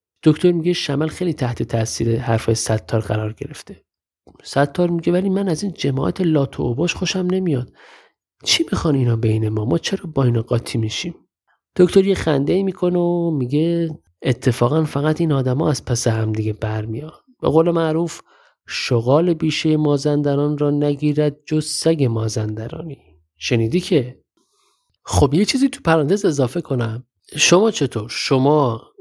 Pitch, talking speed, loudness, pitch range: 145 Hz, 150 wpm, -19 LUFS, 120-170 Hz